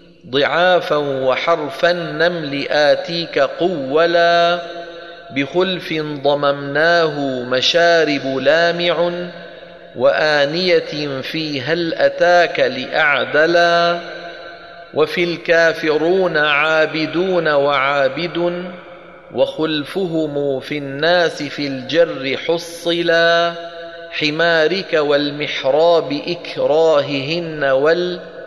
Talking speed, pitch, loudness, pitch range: 55 wpm, 170 Hz, -16 LUFS, 150-170 Hz